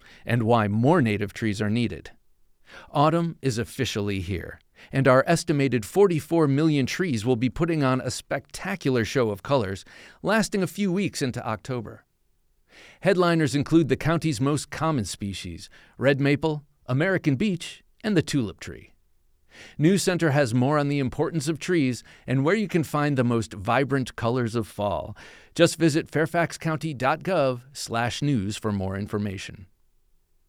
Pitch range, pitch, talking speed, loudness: 110-160 Hz, 135 Hz, 145 wpm, -24 LUFS